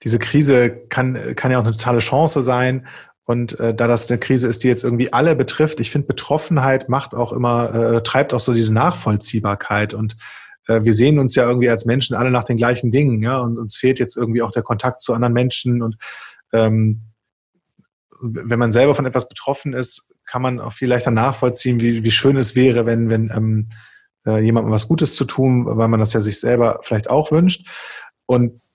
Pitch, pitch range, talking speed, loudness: 120 Hz, 115-130 Hz, 205 wpm, -17 LUFS